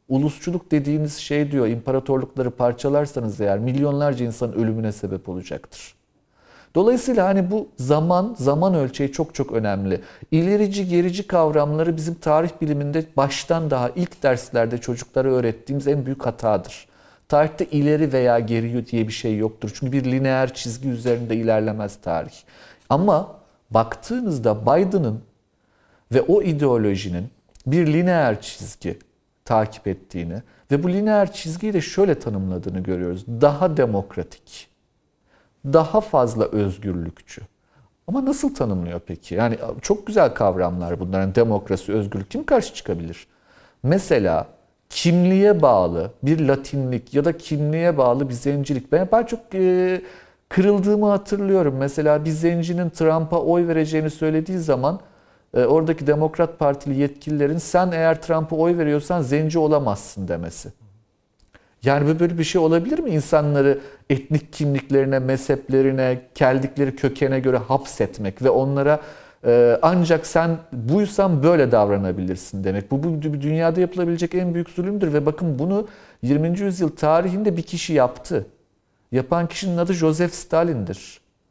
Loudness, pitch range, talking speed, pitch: -21 LUFS, 115-165 Hz, 125 wpm, 140 Hz